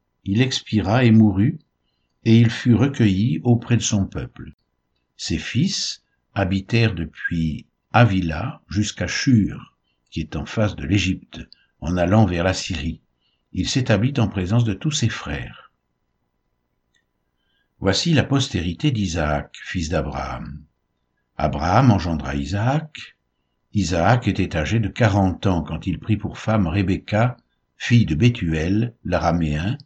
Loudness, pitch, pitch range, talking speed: -21 LUFS, 100 Hz, 80-115 Hz, 125 wpm